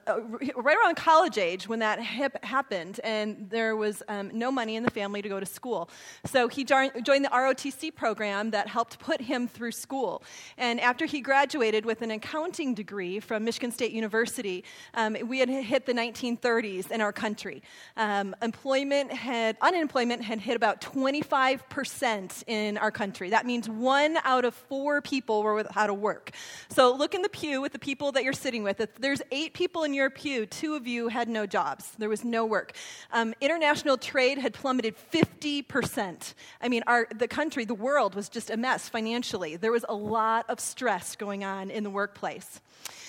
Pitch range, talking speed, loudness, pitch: 220-275 Hz, 190 wpm, -28 LUFS, 240 Hz